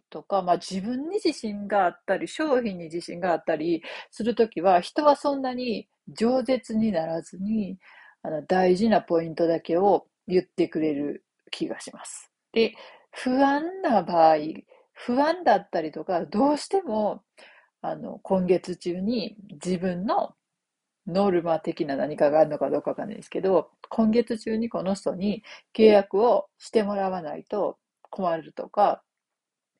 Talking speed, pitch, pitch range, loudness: 285 characters per minute, 205 Hz, 175-245 Hz, -25 LUFS